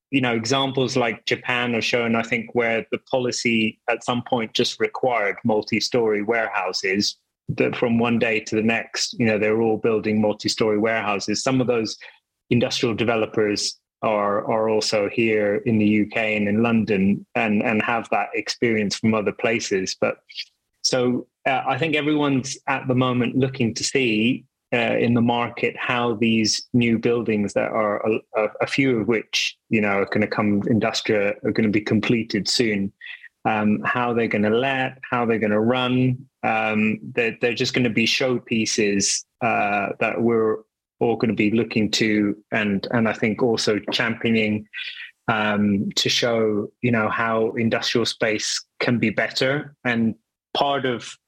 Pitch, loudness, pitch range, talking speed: 115 Hz, -21 LUFS, 110-125 Hz, 170 wpm